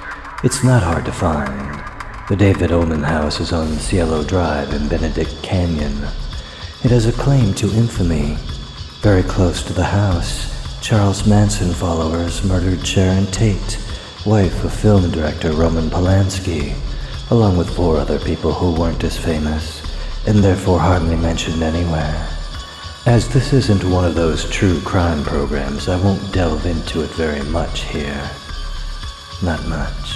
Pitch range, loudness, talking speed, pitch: 75-95 Hz, -17 LUFS, 145 wpm, 85 Hz